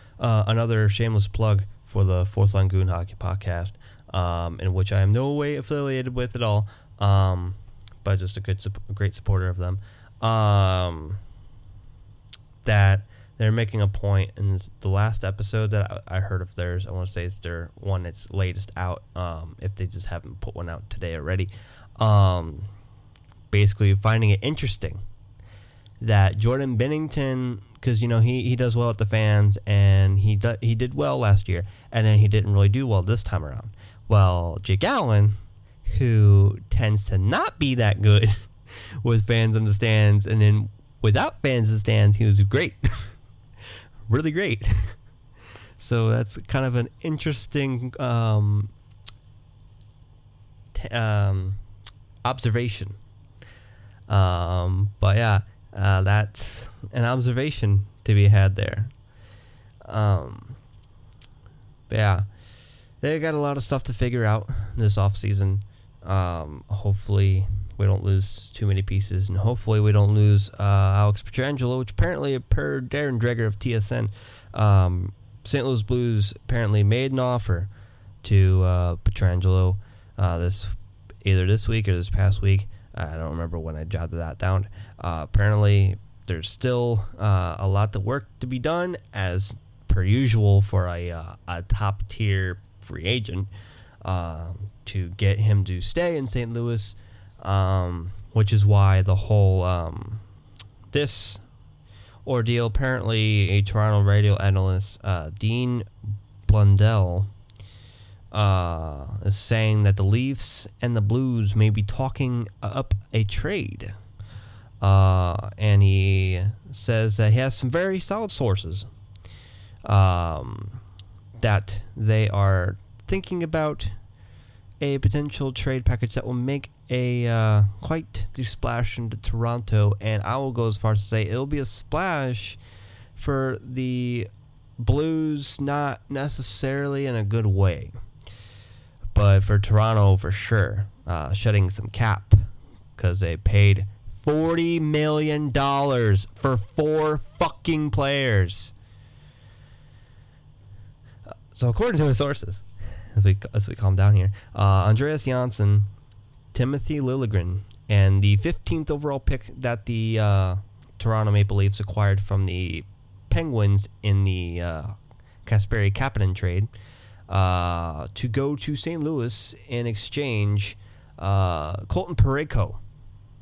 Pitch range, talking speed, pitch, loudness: 100-115 Hz, 140 wpm, 105 Hz, -23 LUFS